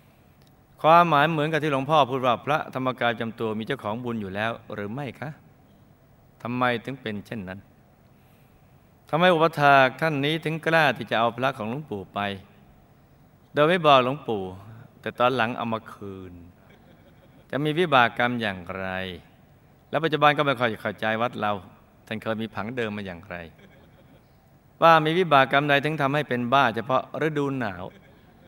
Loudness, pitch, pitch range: -23 LUFS, 125 Hz, 105-140 Hz